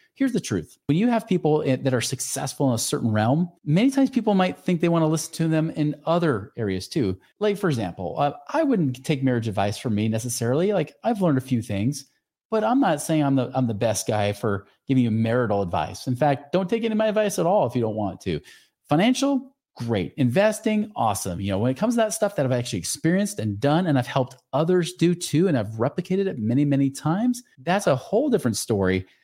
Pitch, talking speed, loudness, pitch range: 145 Hz, 230 wpm, -23 LUFS, 115-185 Hz